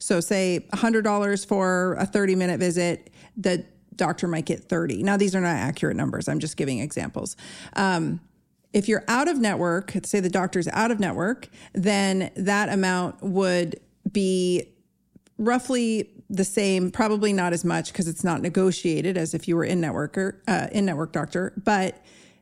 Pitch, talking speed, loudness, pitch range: 190 Hz, 170 wpm, -24 LUFS, 175-205 Hz